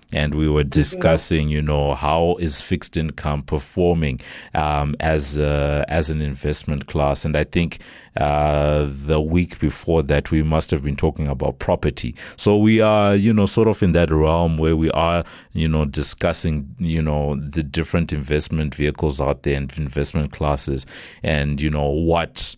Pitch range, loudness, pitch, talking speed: 75-85 Hz, -20 LUFS, 75 Hz, 170 wpm